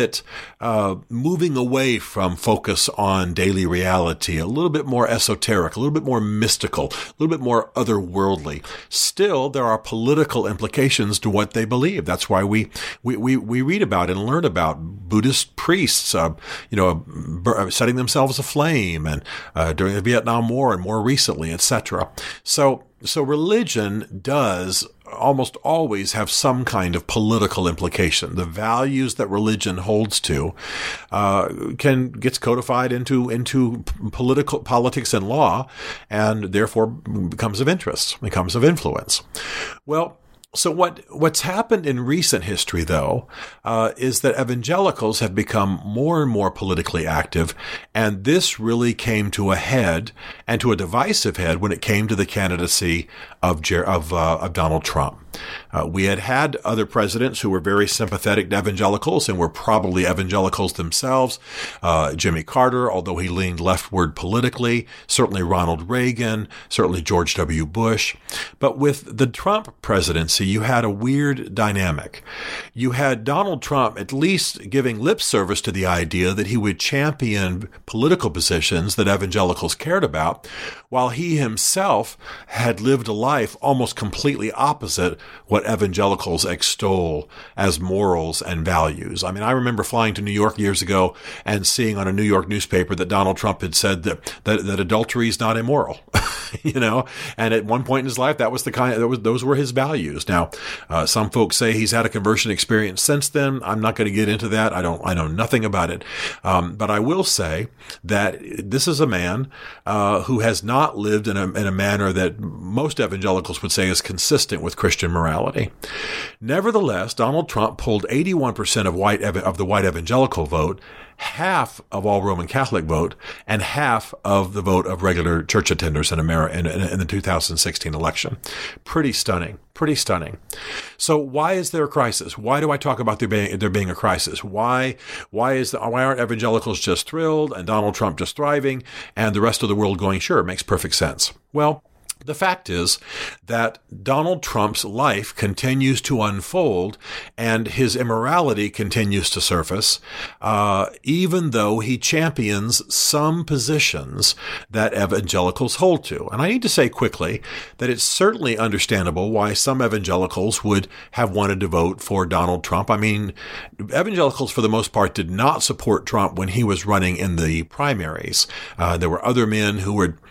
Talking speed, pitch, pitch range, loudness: 170 wpm, 110 Hz, 95-130 Hz, -20 LUFS